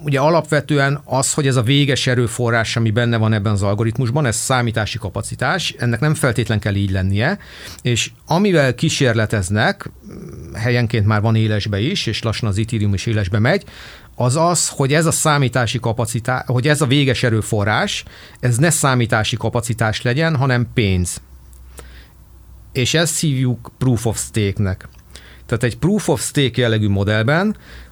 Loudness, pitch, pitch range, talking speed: -17 LUFS, 120 Hz, 105-135 Hz, 150 wpm